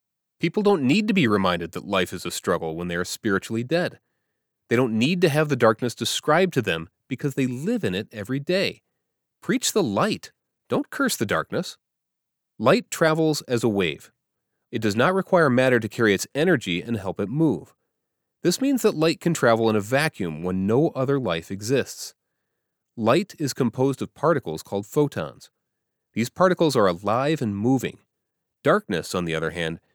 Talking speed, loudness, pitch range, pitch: 180 wpm, -23 LUFS, 100-160 Hz, 125 Hz